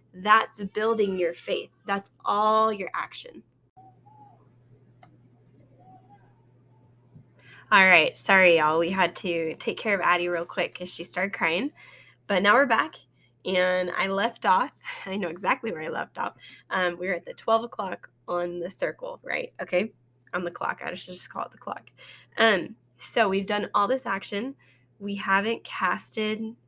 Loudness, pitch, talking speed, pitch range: -25 LUFS, 180 Hz, 160 wpm, 130-205 Hz